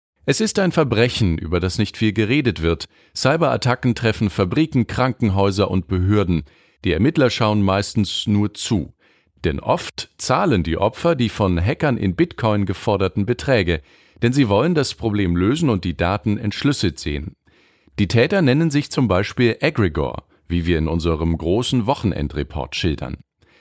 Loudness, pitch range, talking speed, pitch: -19 LUFS, 90-125 Hz, 150 wpm, 105 Hz